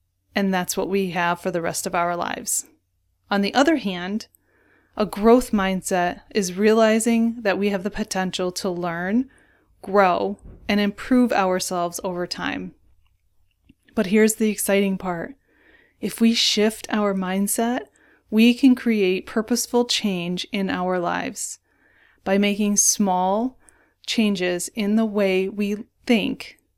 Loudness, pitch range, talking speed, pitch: -21 LUFS, 180-220 Hz, 135 wpm, 200 Hz